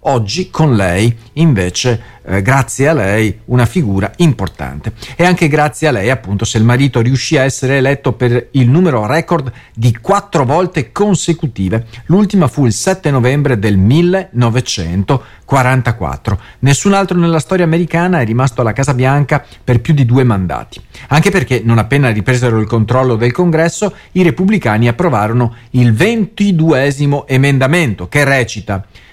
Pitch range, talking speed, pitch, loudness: 115-160 Hz, 145 wpm, 130 Hz, -12 LUFS